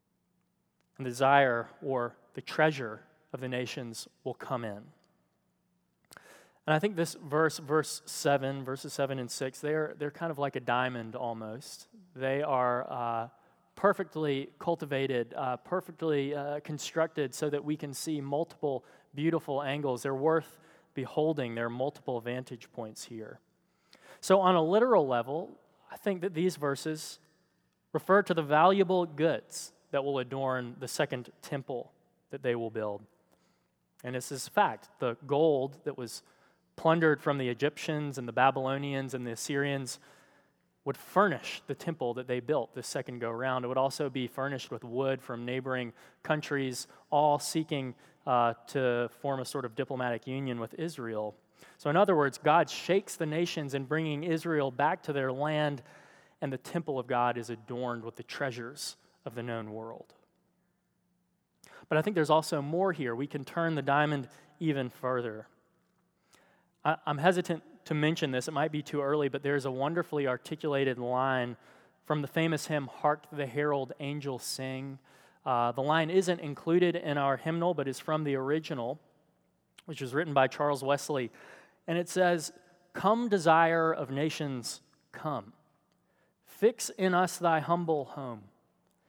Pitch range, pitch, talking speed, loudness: 130-160 Hz, 145 Hz, 155 wpm, -31 LUFS